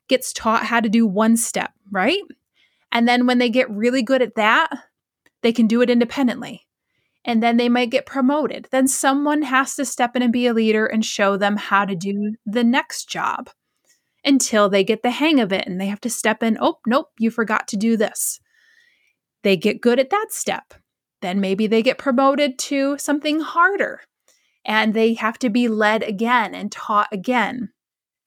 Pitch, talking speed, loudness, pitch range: 240 Hz, 195 wpm, -19 LUFS, 220-270 Hz